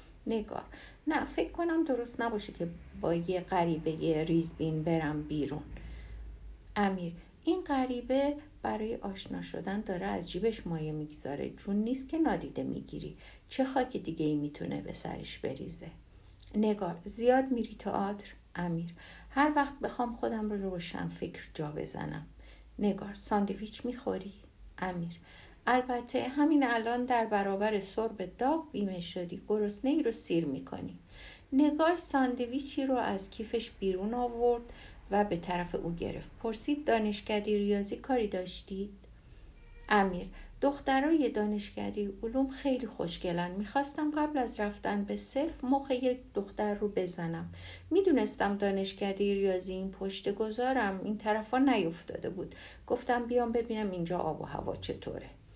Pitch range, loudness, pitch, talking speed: 180-250 Hz, -33 LUFS, 210 Hz, 135 wpm